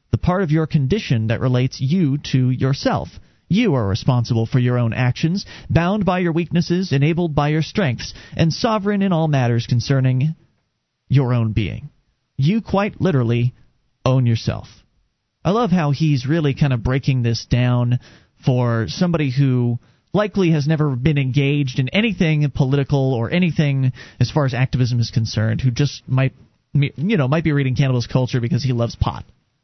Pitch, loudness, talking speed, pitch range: 135 Hz, -19 LUFS, 165 wpm, 125-160 Hz